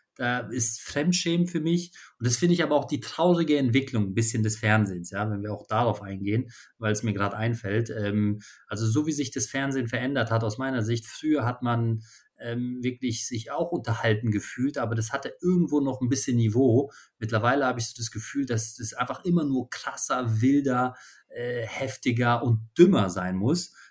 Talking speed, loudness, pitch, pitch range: 195 wpm, -26 LUFS, 120 Hz, 110-135 Hz